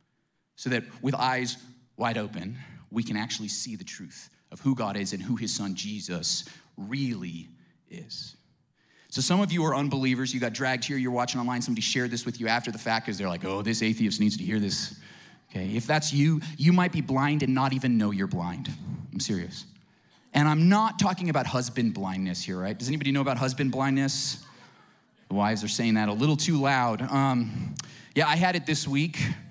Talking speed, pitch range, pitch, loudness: 205 wpm, 110-140 Hz, 125 Hz, -27 LUFS